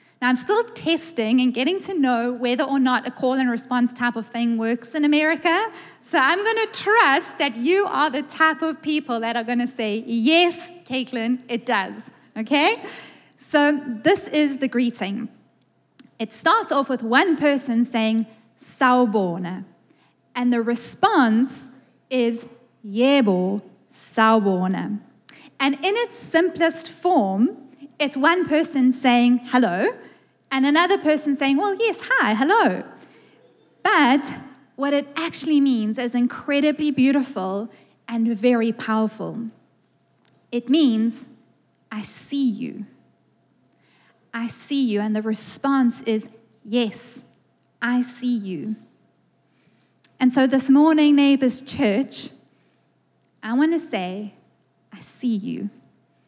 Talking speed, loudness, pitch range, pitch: 130 wpm, -20 LUFS, 235-295 Hz, 255 Hz